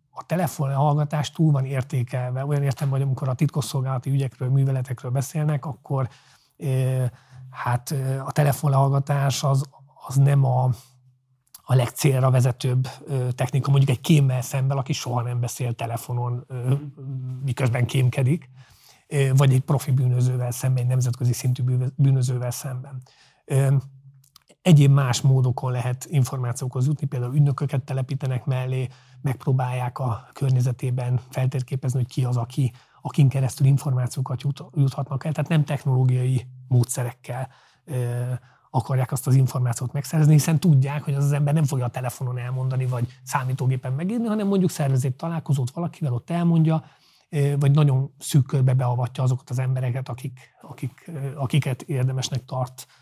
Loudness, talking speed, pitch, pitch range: -23 LUFS, 130 wpm, 130 Hz, 130-140 Hz